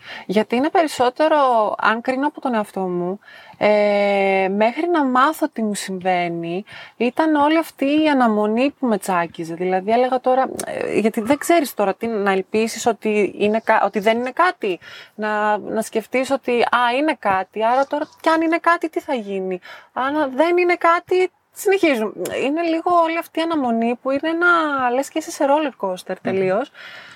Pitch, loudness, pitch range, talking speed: 250 Hz, -19 LUFS, 210-310 Hz, 170 wpm